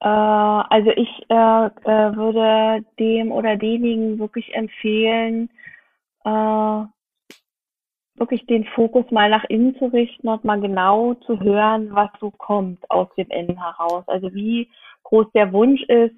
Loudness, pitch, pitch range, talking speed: -19 LUFS, 220 Hz, 210-230 Hz, 135 wpm